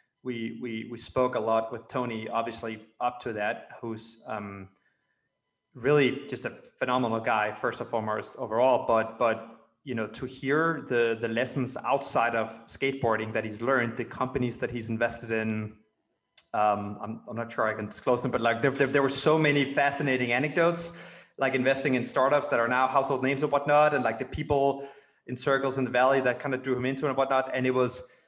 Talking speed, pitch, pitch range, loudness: 200 wpm, 125 Hz, 115-135 Hz, -28 LUFS